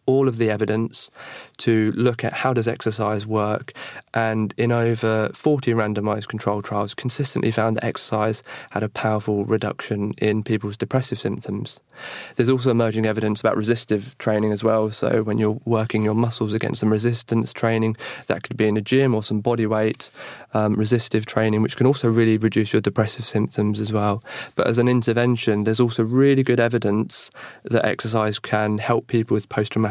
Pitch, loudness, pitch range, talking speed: 110 Hz, -22 LUFS, 110-120 Hz, 180 wpm